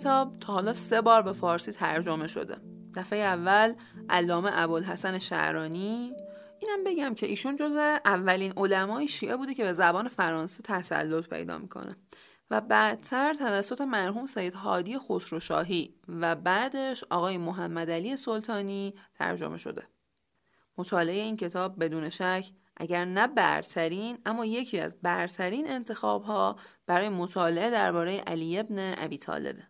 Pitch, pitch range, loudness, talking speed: 190 Hz, 175-225 Hz, -29 LUFS, 130 wpm